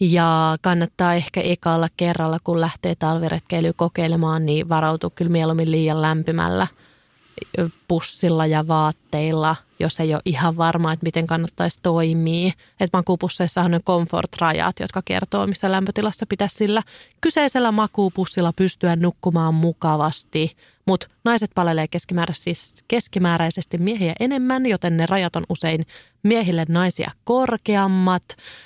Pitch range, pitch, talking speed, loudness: 160-185 Hz, 170 Hz, 115 wpm, -21 LUFS